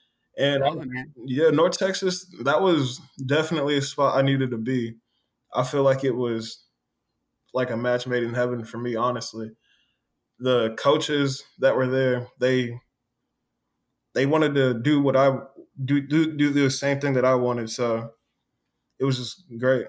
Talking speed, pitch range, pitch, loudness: 165 wpm, 125-140 Hz, 130 Hz, -24 LUFS